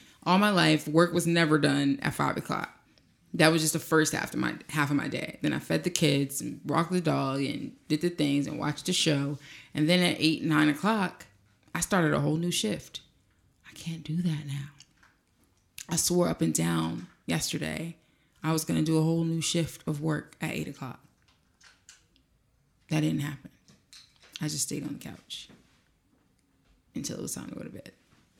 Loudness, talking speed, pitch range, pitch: -28 LUFS, 195 wpm, 140-165 Hz, 155 Hz